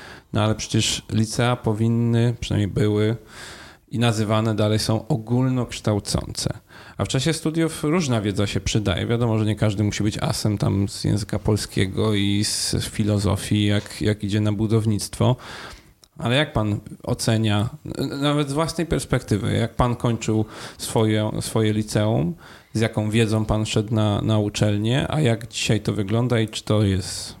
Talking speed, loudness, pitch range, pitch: 155 wpm, -22 LUFS, 105-120 Hz, 110 Hz